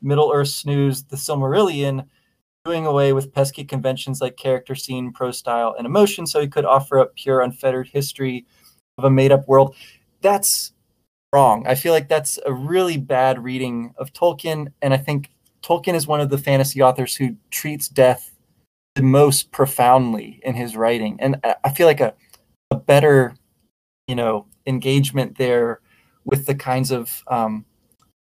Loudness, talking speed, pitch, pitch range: -19 LUFS, 165 wpm, 135 Hz, 125-140 Hz